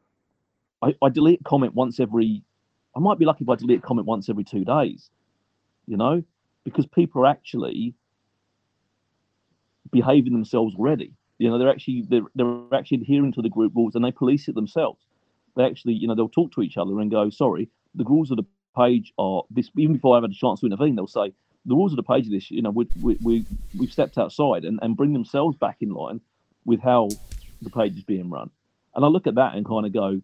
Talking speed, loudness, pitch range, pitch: 220 wpm, -22 LUFS, 110-135 Hz, 120 Hz